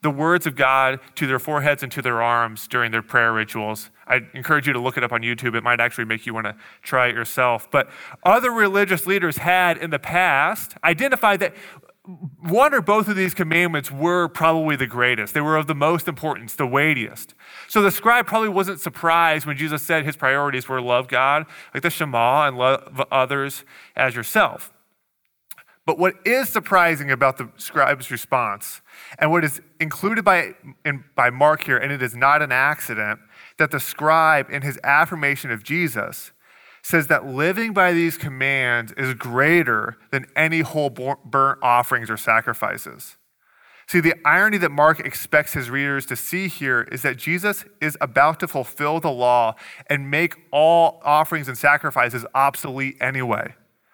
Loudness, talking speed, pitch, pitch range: -20 LUFS, 175 wpm, 145 Hz, 130-170 Hz